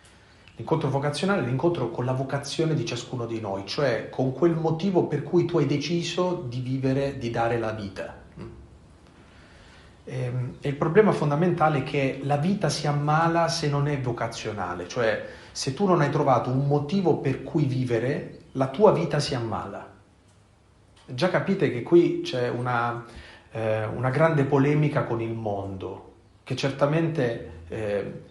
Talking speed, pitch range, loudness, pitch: 155 wpm, 110-155 Hz, -25 LUFS, 130 Hz